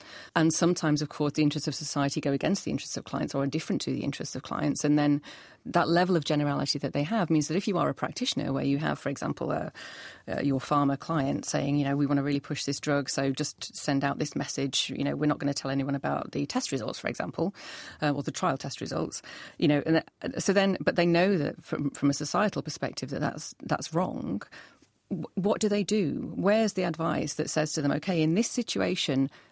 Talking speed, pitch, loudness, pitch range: 240 wpm, 150 Hz, -28 LUFS, 140-170 Hz